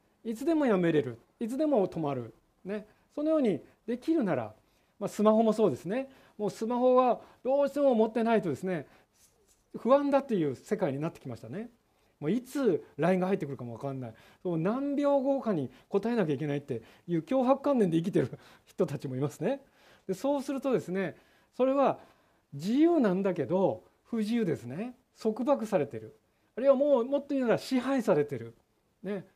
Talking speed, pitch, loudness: 370 characters per minute, 210 Hz, -30 LUFS